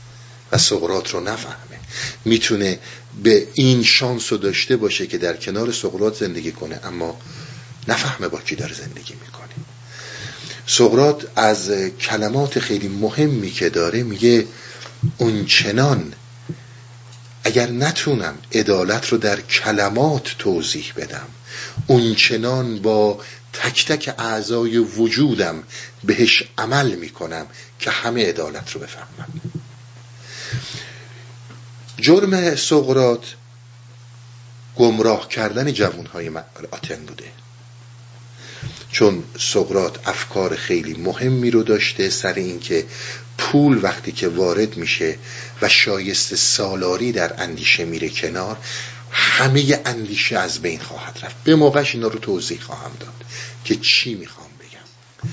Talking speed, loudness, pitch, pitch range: 110 wpm, -18 LUFS, 120 Hz, 115-130 Hz